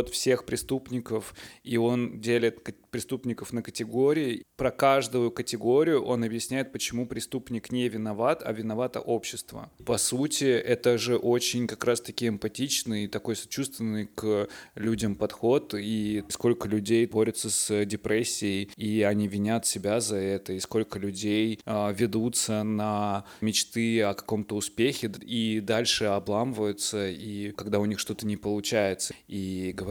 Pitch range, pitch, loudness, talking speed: 105-120 Hz, 110 Hz, -28 LUFS, 135 wpm